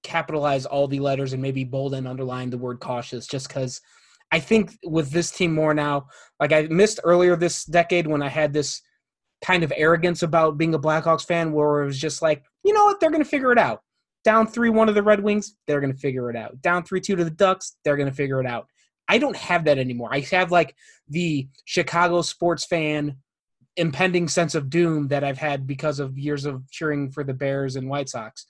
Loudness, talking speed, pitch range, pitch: -22 LUFS, 225 wpm, 140-175 Hz, 155 Hz